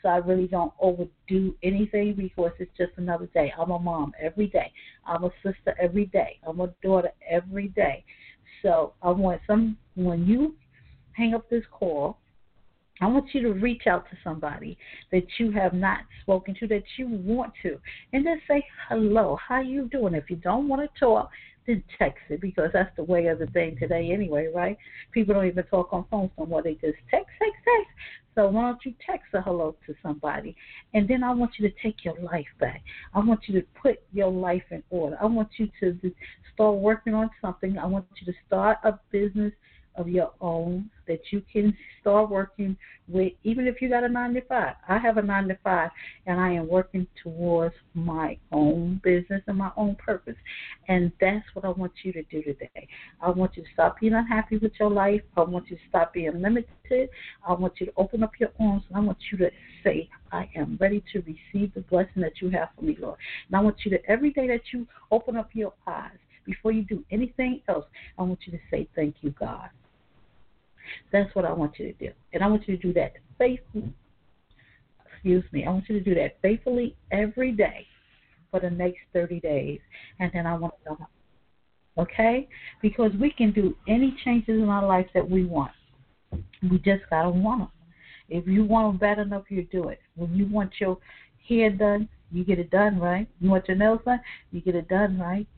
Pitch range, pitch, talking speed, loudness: 175-215 Hz, 190 Hz, 210 wpm, -26 LUFS